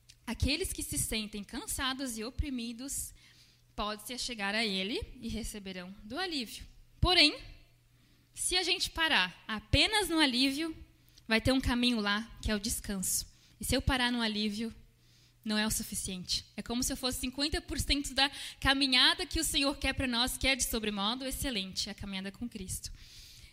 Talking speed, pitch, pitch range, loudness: 165 wpm, 235 Hz, 205-275 Hz, -31 LUFS